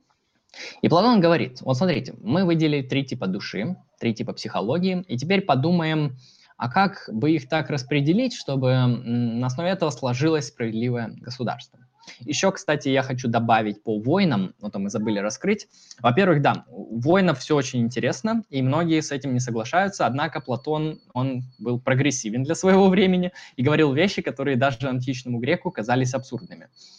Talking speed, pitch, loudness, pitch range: 155 wpm, 140 Hz, -23 LUFS, 125-170 Hz